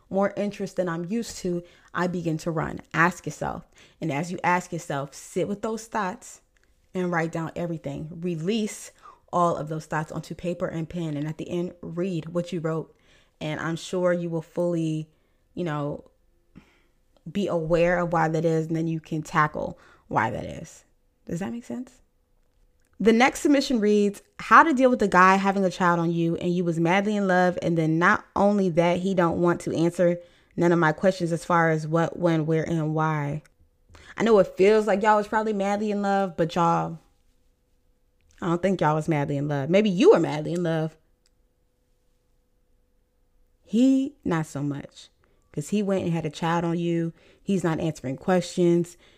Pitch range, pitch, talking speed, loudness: 160-190 Hz, 170 Hz, 190 wpm, -24 LUFS